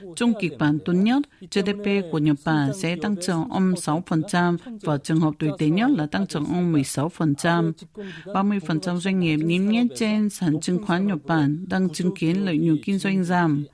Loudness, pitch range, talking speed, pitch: -23 LUFS, 155-195 Hz, 190 wpm, 175 Hz